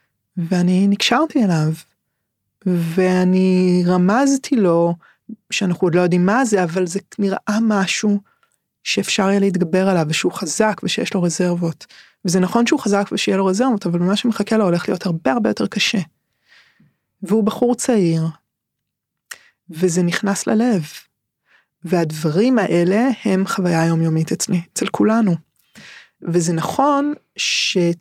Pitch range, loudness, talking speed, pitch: 175-210 Hz, -18 LUFS, 125 wpm, 185 Hz